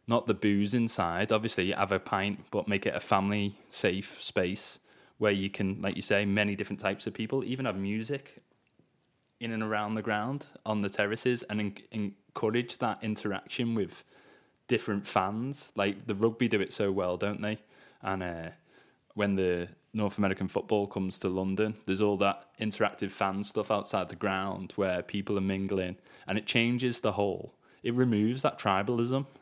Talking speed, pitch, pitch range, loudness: 175 wpm, 105 Hz, 100-110 Hz, -31 LUFS